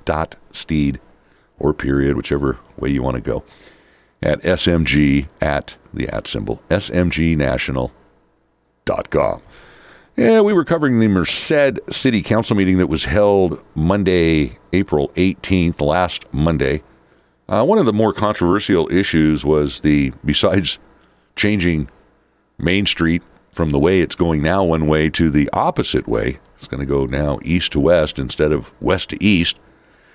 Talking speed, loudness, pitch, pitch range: 145 wpm, -17 LUFS, 80 Hz, 70-90 Hz